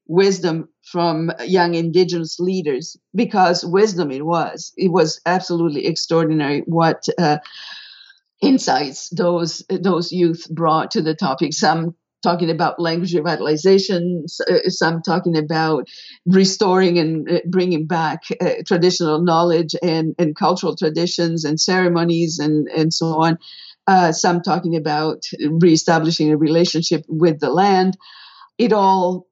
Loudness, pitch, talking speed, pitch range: -18 LUFS, 170 Hz, 125 wpm, 160-185 Hz